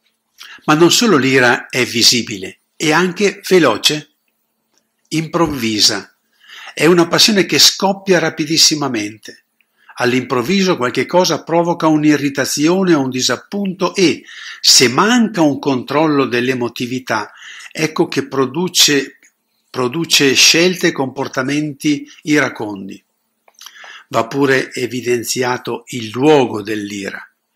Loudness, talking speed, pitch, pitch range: -13 LUFS, 95 wpm, 145 Hz, 125-170 Hz